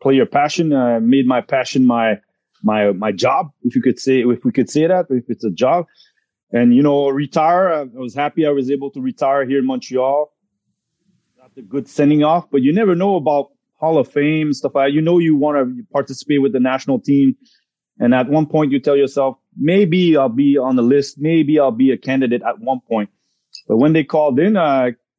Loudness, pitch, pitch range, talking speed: -16 LUFS, 140 Hz, 130-155 Hz, 220 wpm